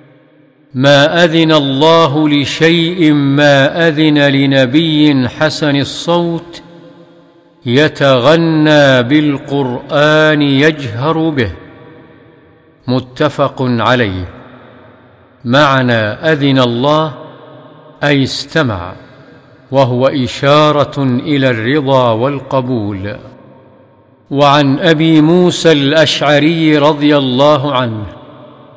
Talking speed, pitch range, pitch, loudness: 65 wpm, 130-155 Hz, 145 Hz, -10 LUFS